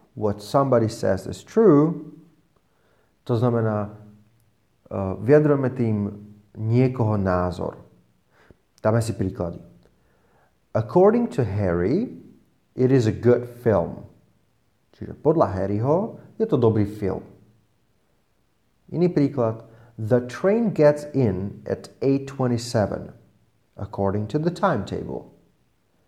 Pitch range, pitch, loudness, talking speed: 105-135 Hz, 115 Hz, -22 LUFS, 95 wpm